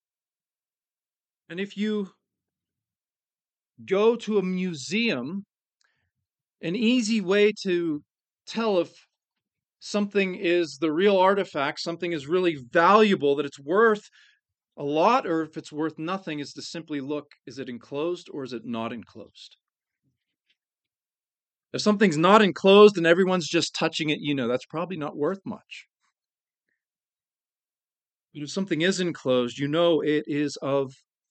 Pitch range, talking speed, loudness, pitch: 150-200 Hz, 135 wpm, -24 LUFS, 170 Hz